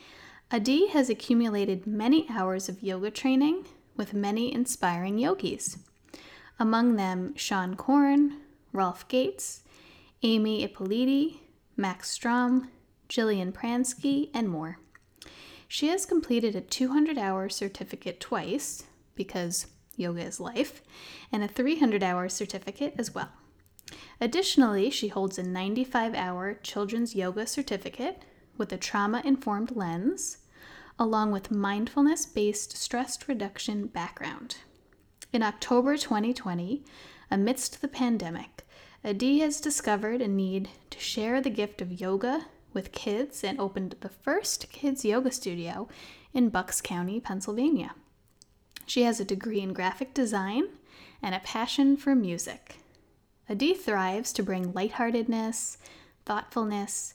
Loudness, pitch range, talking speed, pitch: -29 LUFS, 195-265 Hz, 115 wpm, 225 Hz